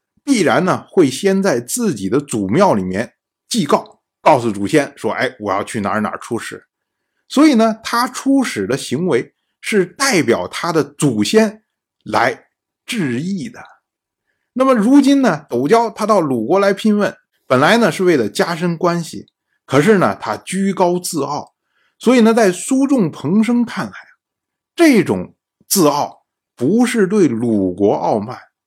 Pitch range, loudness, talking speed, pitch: 170-235 Hz, -15 LUFS, 215 characters per minute, 205 Hz